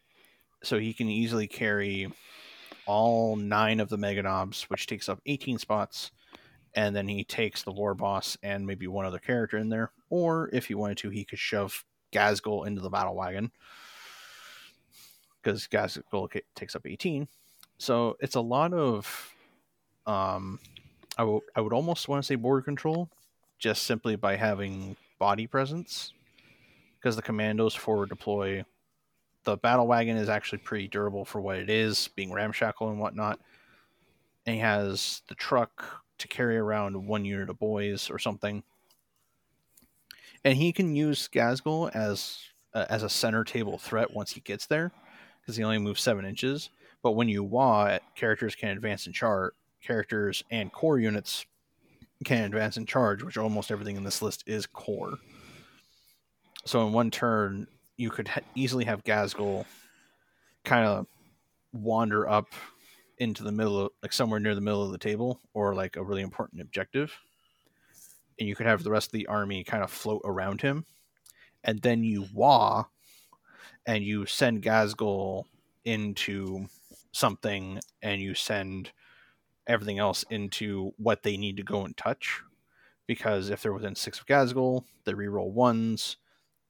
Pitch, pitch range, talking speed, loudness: 105 Hz, 100-115 Hz, 160 wpm, -30 LUFS